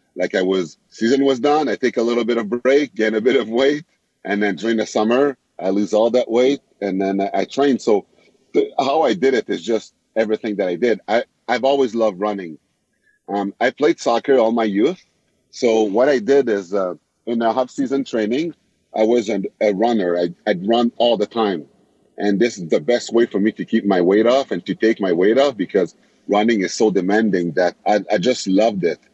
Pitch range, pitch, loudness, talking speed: 100-125 Hz, 115 Hz, -18 LUFS, 225 wpm